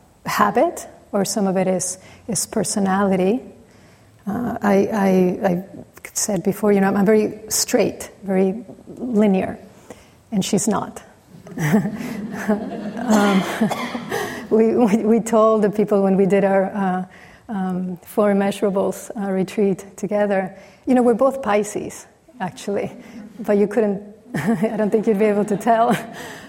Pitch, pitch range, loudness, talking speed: 205 Hz, 195-220 Hz, -20 LUFS, 135 wpm